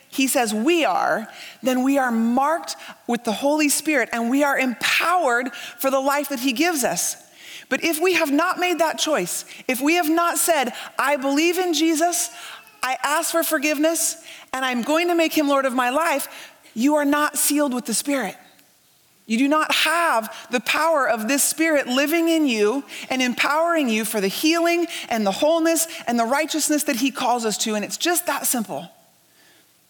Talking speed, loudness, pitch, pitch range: 190 wpm, -20 LUFS, 290 Hz, 250-325 Hz